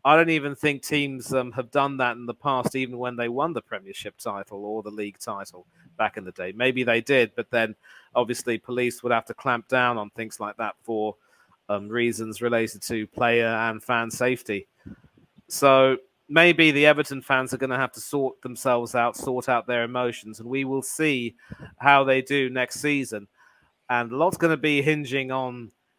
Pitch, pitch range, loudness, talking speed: 125 Hz, 115-135 Hz, -24 LUFS, 200 wpm